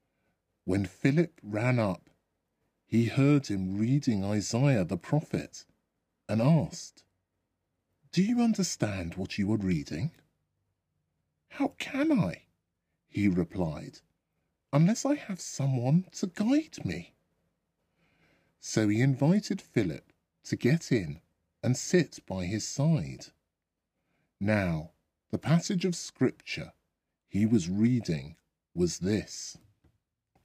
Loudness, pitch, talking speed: -29 LUFS, 115 Hz, 105 wpm